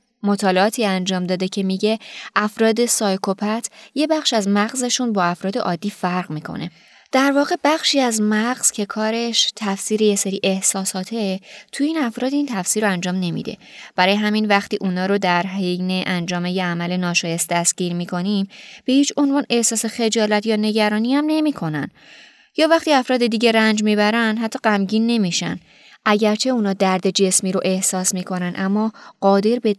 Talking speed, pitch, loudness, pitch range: 155 wpm, 210 Hz, -19 LUFS, 185-230 Hz